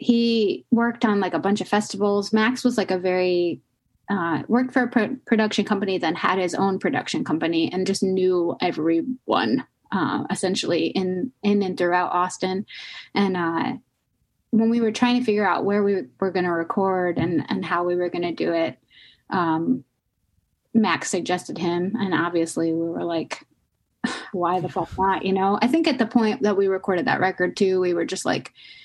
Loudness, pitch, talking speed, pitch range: -23 LUFS, 190 Hz, 190 wpm, 175-215 Hz